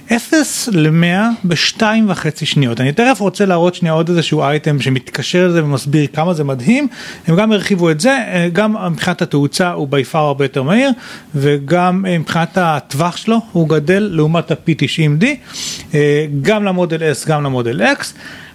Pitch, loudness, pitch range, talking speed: 170 Hz, -14 LUFS, 150-205 Hz, 150 wpm